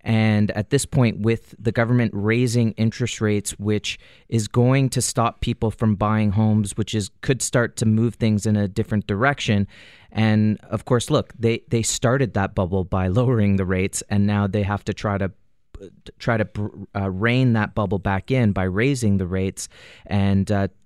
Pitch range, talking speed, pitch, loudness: 100-115 Hz, 185 wpm, 105 Hz, -21 LUFS